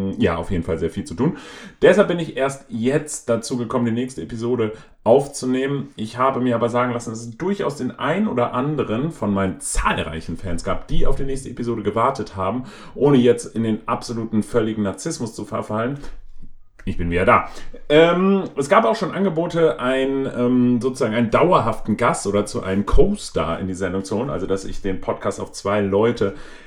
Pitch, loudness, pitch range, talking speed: 120 Hz, -21 LUFS, 100-135 Hz, 195 wpm